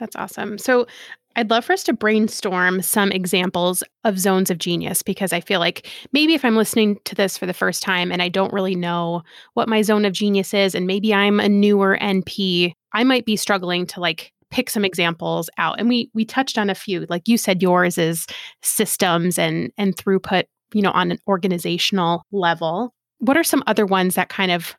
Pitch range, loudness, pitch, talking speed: 180-220 Hz, -19 LUFS, 195 Hz, 210 wpm